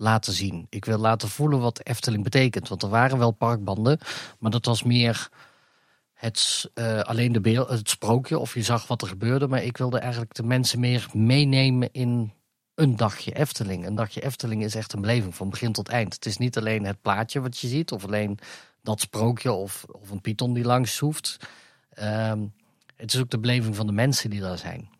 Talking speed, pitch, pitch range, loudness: 205 wpm, 115 Hz, 110-125 Hz, -25 LUFS